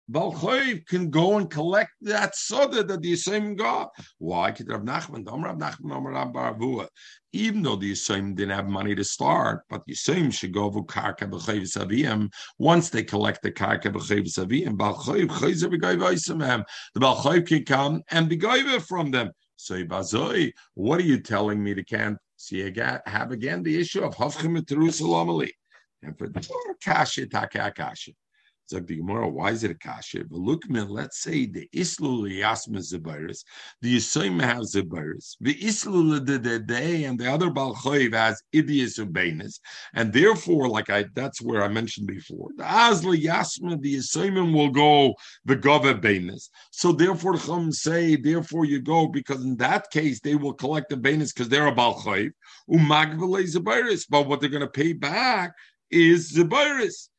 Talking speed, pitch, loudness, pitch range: 155 wpm, 145 Hz, -24 LUFS, 110-175 Hz